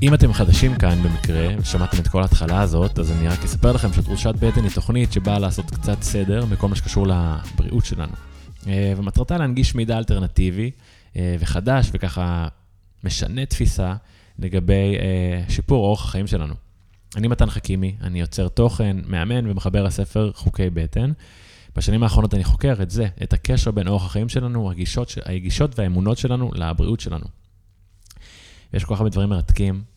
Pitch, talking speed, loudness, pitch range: 100 Hz, 150 wpm, -21 LUFS, 90-110 Hz